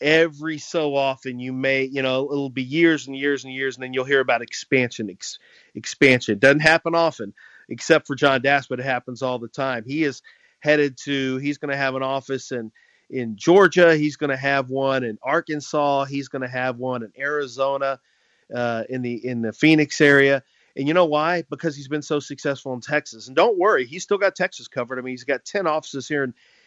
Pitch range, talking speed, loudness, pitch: 130-150 Hz, 215 wpm, -21 LUFS, 140 Hz